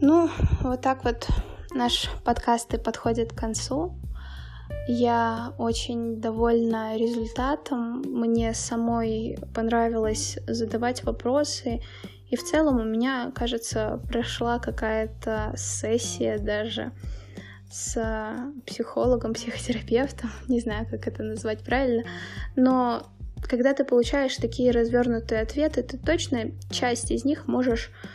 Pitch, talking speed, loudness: 230 Hz, 110 wpm, -26 LUFS